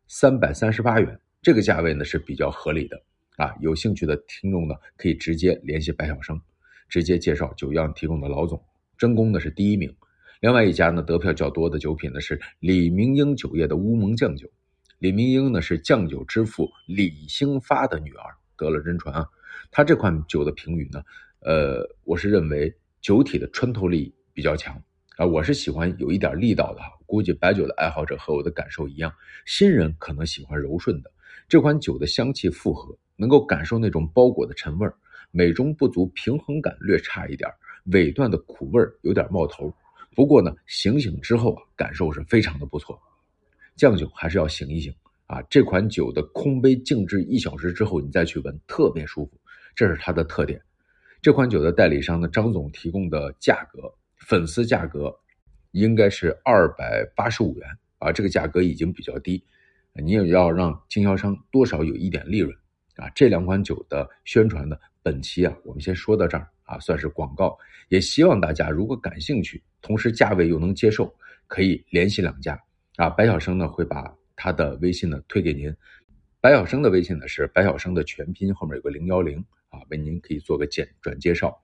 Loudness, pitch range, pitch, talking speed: -22 LUFS, 80-110 Hz, 90 Hz, 290 characters per minute